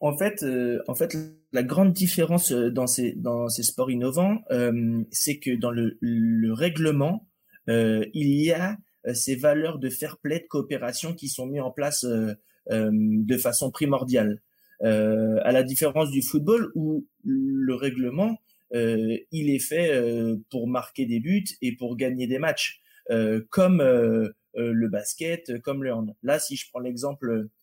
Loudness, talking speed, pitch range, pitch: -25 LUFS, 170 wpm, 120-155 Hz, 130 Hz